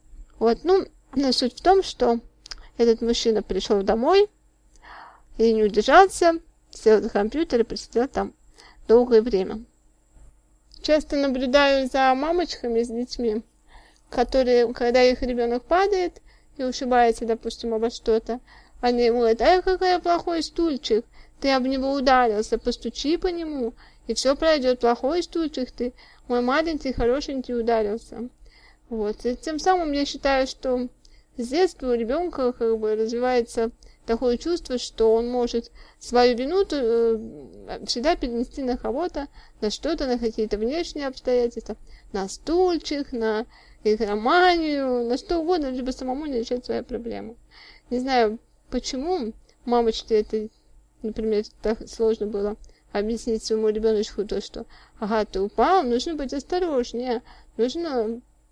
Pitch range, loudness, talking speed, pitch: 225-280 Hz, -23 LUFS, 135 wpm, 245 Hz